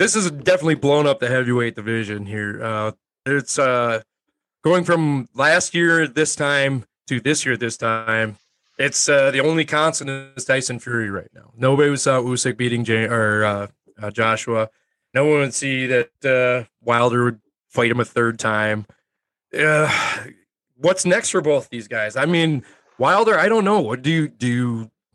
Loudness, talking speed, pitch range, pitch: -19 LUFS, 175 wpm, 115-145 Hz, 125 Hz